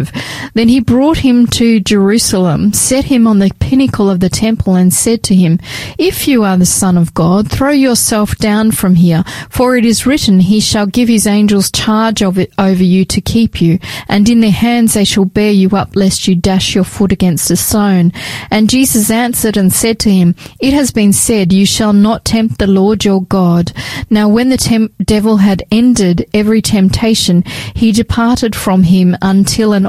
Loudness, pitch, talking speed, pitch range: -10 LUFS, 205 Hz, 195 wpm, 190-225 Hz